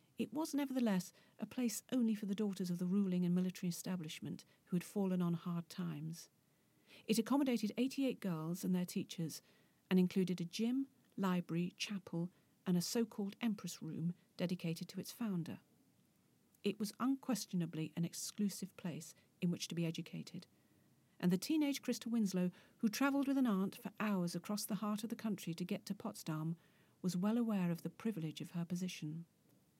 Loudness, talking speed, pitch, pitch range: -40 LUFS, 175 wpm, 185 Hz, 170-220 Hz